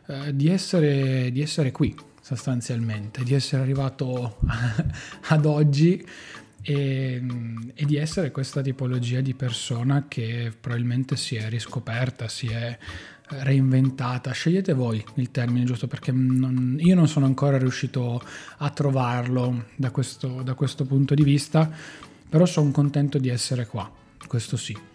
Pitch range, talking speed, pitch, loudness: 125-145 Hz, 135 wpm, 130 Hz, -24 LUFS